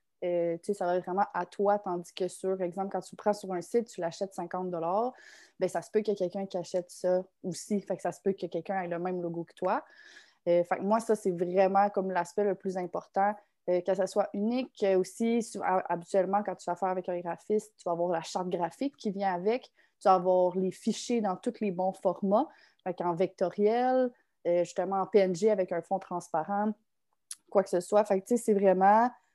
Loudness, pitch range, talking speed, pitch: -30 LUFS, 180-205 Hz, 225 wpm, 190 Hz